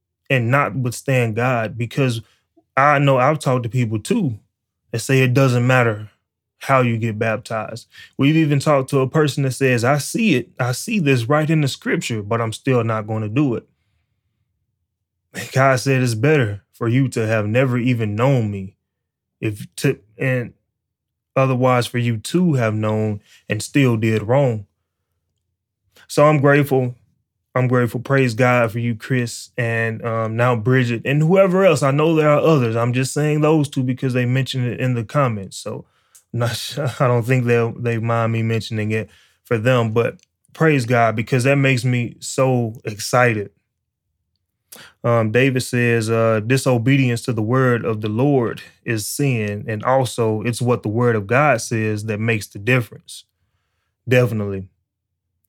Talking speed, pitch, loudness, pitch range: 170 wpm, 120 Hz, -18 LUFS, 110-130 Hz